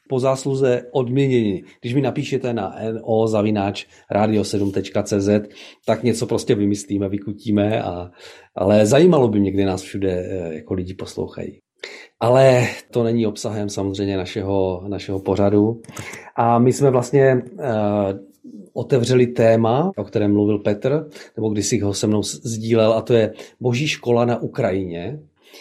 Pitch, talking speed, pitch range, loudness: 110 Hz, 135 wpm, 100-125 Hz, -19 LUFS